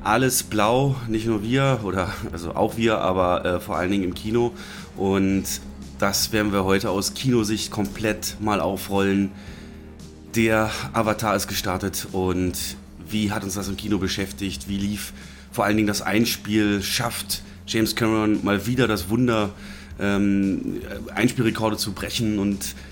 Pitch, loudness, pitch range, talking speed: 100 Hz, -23 LUFS, 95-110 Hz, 150 wpm